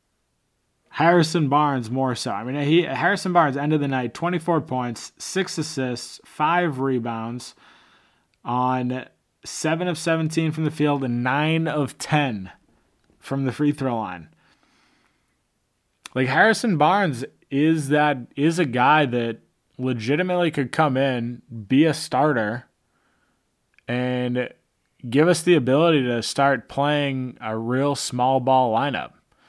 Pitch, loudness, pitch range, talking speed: 140 Hz, -22 LUFS, 125-155 Hz, 130 wpm